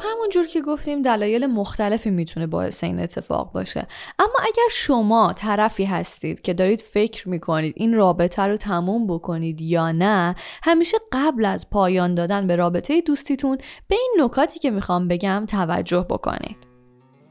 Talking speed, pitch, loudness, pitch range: 150 wpm, 205 Hz, -21 LUFS, 175-275 Hz